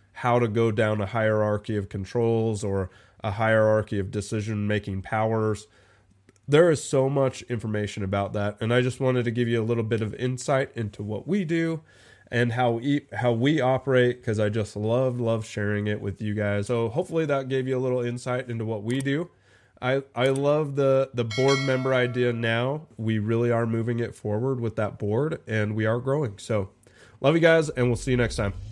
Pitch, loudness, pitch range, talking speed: 115 Hz, -25 LUFS, 105-130 Hz, 205 wpm